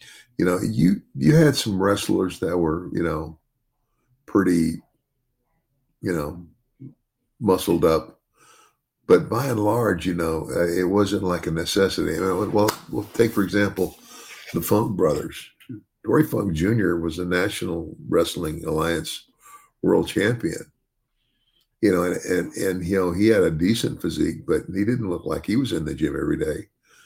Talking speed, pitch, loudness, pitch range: 160 wpm, 105 Hz, -22 LUFS, 90-125 Hz